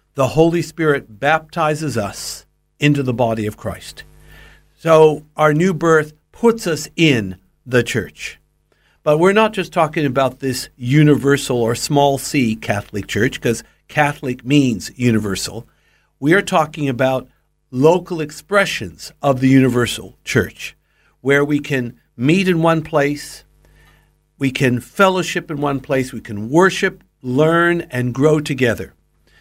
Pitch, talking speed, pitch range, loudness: 140 Hz, 135 wpm, 120-155 Hz, -17 LUFS